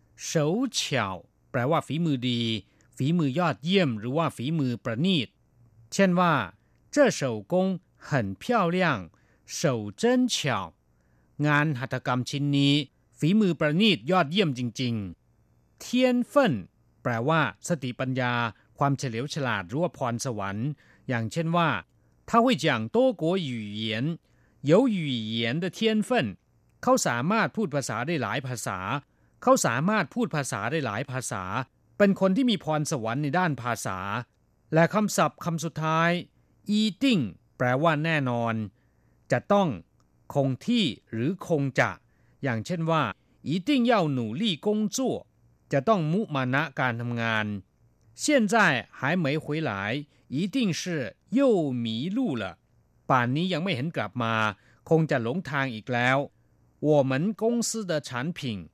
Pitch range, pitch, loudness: 120-180 Hz, 145 Hz, -26 LUFS